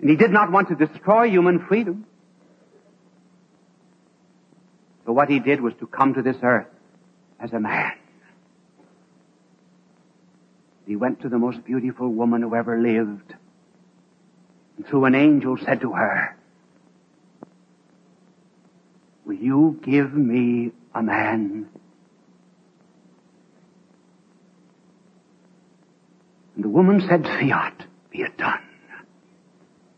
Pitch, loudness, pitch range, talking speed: 125 Hz, -21 LUFS, 110-165 Hz, 105 wpm